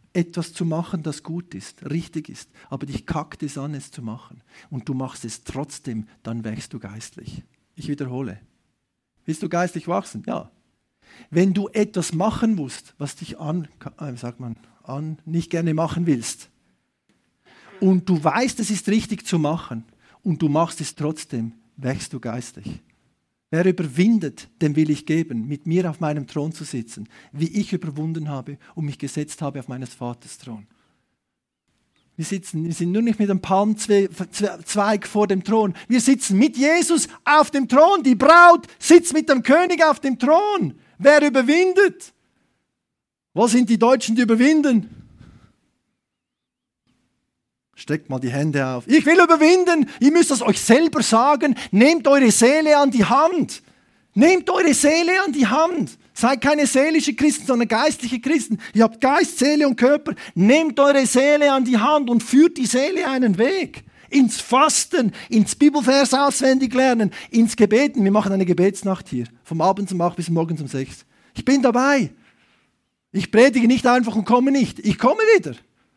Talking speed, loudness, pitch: 165 wpm, -18 LUFS, 205 Hz